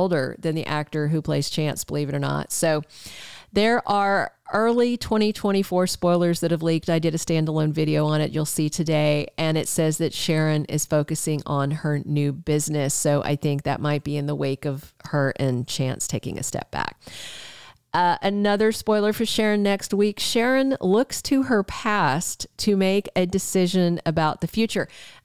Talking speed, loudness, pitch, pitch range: 185 wpm, -23 LUFS, 160 Hz, 150-195 Hz